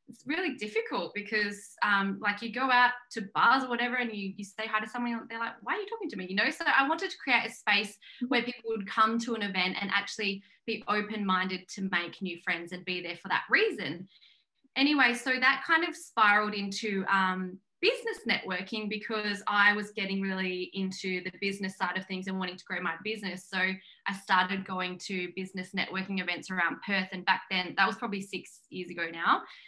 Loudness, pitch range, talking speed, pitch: -30 LUFS, 185-230 Hz, 215 wpm, 205 Hz